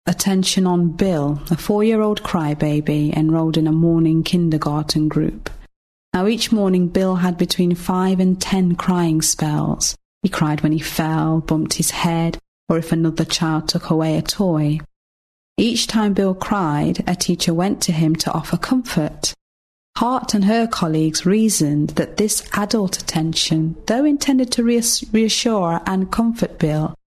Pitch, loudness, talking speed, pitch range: 175 Hz, -18 LUFS, 150 wpm, 160-200 Hz